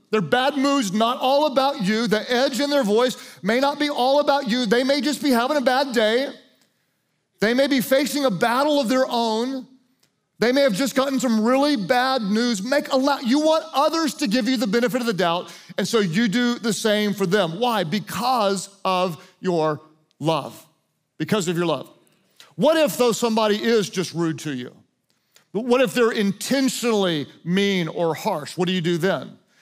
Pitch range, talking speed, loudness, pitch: 190-265 Hz, 195 wpm, -21 LUFS, 235 Hz